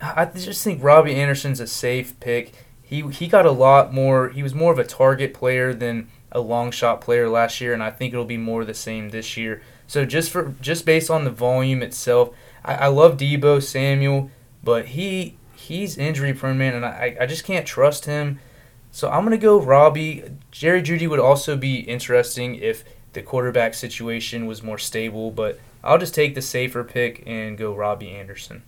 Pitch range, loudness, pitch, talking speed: 120-150 Hz, -20 LUFS, 130 Hz, 200 wpm